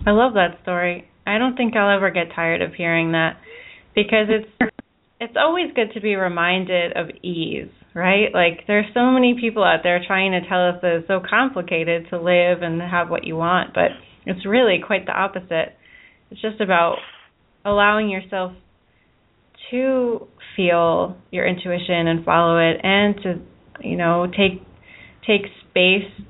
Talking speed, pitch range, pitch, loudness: 165 wpm, 175-210 Hz, 185 Hz, -19 LUFS